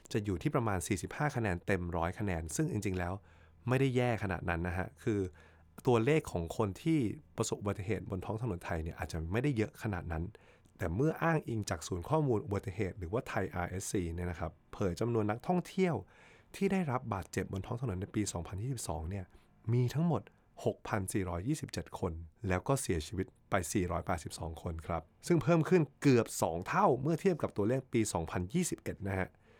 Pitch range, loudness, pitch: 90-125 Hz, -35 LUFS, 105 Hz